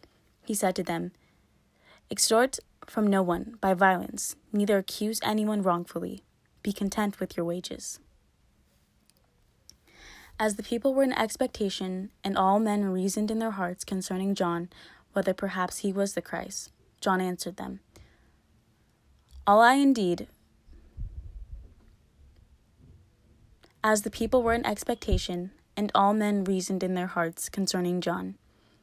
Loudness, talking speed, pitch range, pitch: -28 LUFS, 125 wpm, 170-210 Hz, 190 Hz